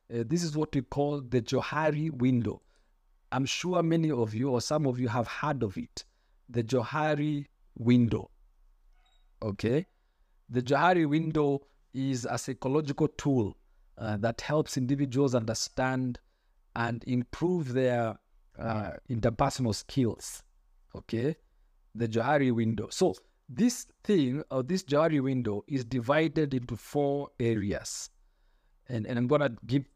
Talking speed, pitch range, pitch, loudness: 130 wpm, 115-150 Hz, 130 Hz, -30 LUFS